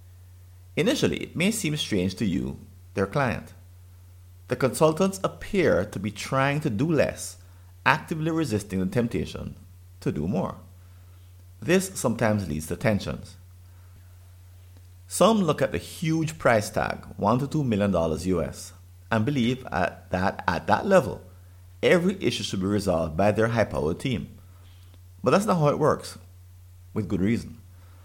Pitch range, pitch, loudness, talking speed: 90-115 Hz, 95 Hz, -25 LUFS, 145 wpm